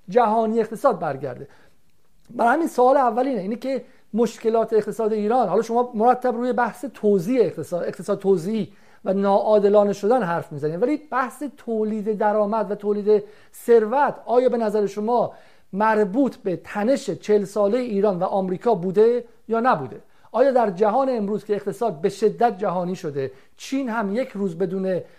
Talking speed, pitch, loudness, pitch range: 150 wpm, 220 Hz, -22 LUFS, 200-245 Hz